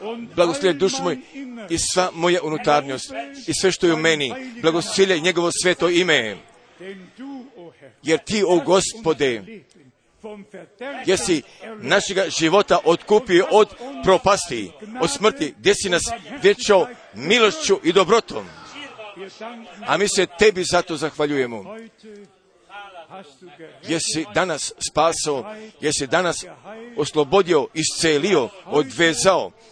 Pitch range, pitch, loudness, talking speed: 165-215 Hz, 185 Hz, -19 LUFS, 100 wpm